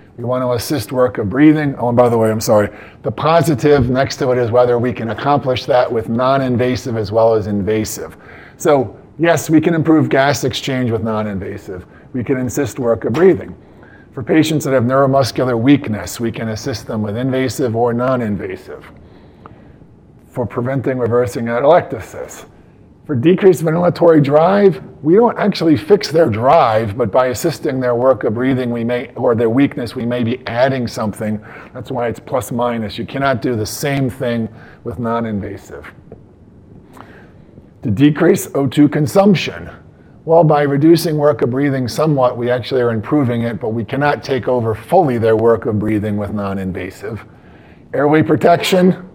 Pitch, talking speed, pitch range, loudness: 125 Hz, 165 wpm, 115-145 Hz, -15 LUFS